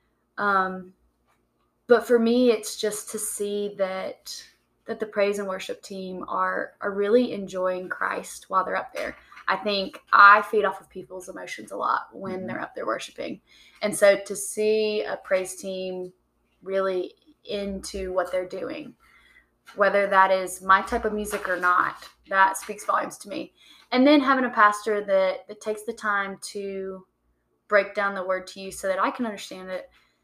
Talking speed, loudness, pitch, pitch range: 175 wpm, -24 LUFS, 200 Hz, 190-215 Hz